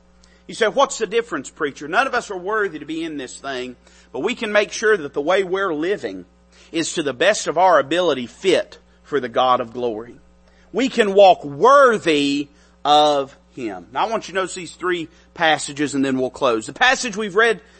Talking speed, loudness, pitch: 210 wpm, -19 LUFS, 165 Hz